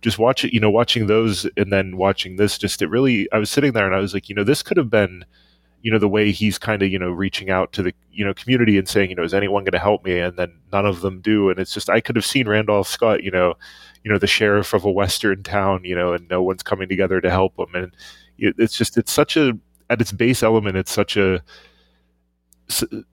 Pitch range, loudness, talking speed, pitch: 95-110 Hz, -19 LUFS, 265 wpm, 100 Hz